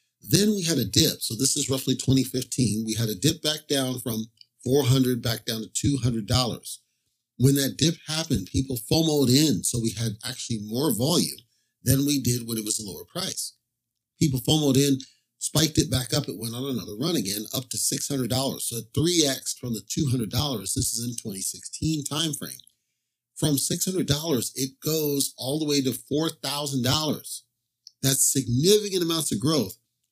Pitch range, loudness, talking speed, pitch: 120-145 Hz, -25 LUFS, 170 wpm, 130 Hz